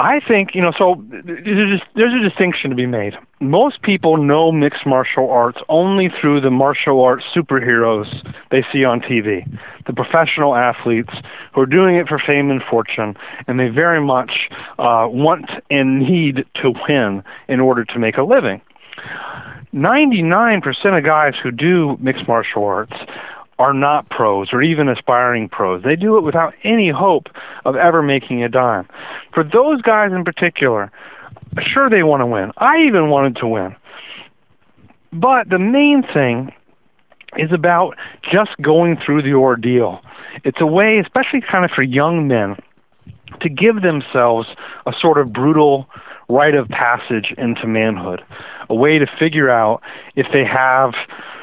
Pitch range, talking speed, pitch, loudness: 125-175 Hz, 160 wpm, 145 Hz, -15 LUFS